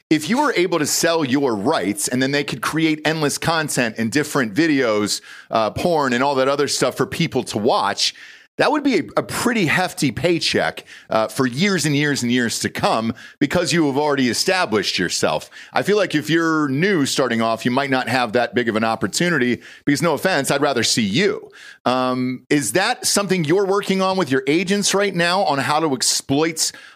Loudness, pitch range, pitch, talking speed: -19 LUFS, 125-170 Hz, 145 Hz, 205 wpm